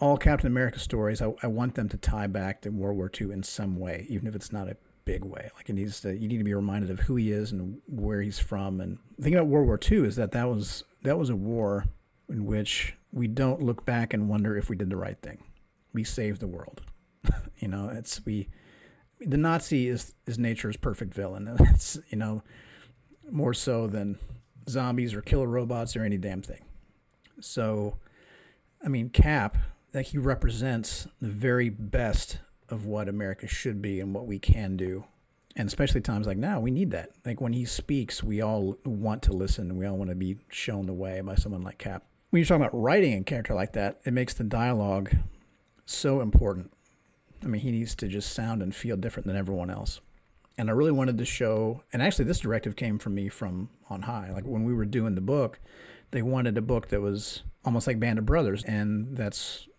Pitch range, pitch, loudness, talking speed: 100-120 Hz, 105 Hz, -29 LUFS, 215 wpm